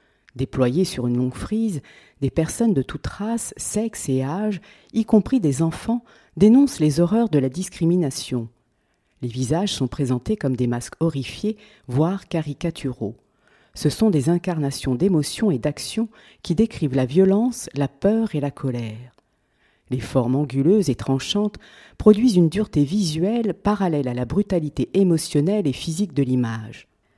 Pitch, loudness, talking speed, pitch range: 155 Hz, -22 LUFS, 150 wpm, 130-205 Hz